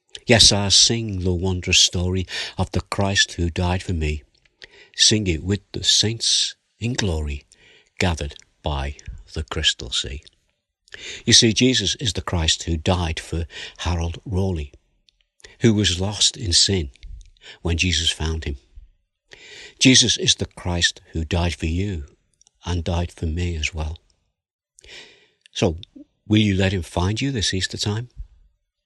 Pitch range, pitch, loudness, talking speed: 80-100 Hz, 90 Hz, -19 LUFS, 145 wpm